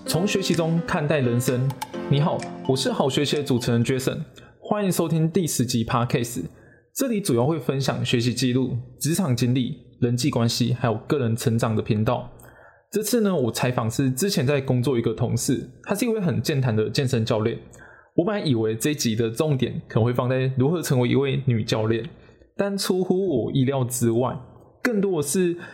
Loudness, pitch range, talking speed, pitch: -23 LUFS, 120-160 Hz, 305 characters per minute, 130 Hz